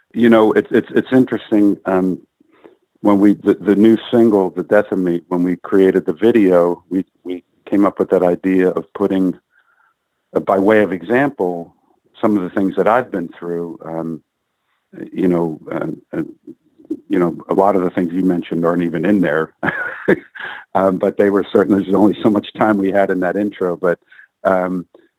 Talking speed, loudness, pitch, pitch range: 190 wpm, -16 LUFS, 95 Hz, 90-105 Hz